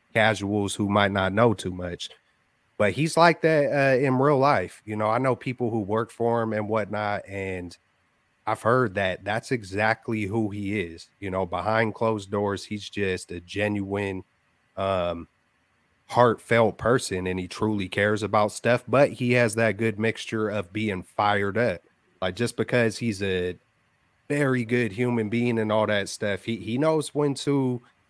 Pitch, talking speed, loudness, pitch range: 110 Hz, 175 wpm, -25 LUFS, 100-120 Hz